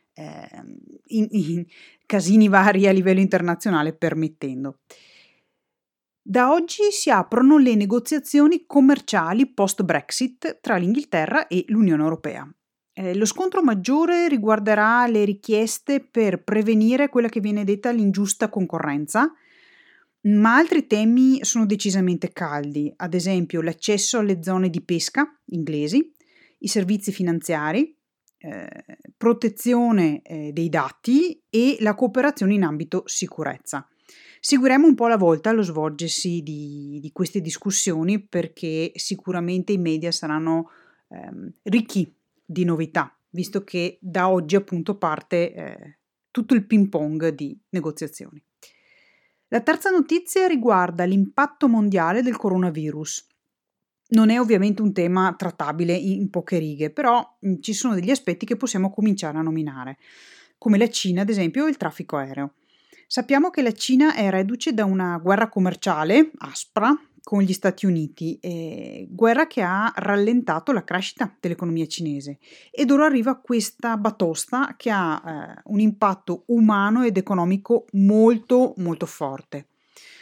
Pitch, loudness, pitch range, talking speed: 200 Hz, -21 LUFS, 175-240 Hz, 130 wpm